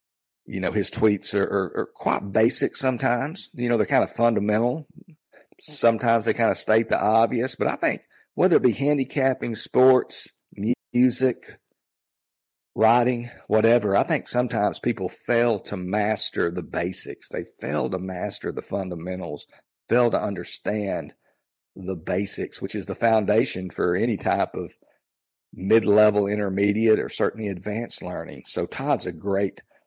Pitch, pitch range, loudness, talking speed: 110 Hz, 100-120 Hz, -24 LUFS, 145 wpm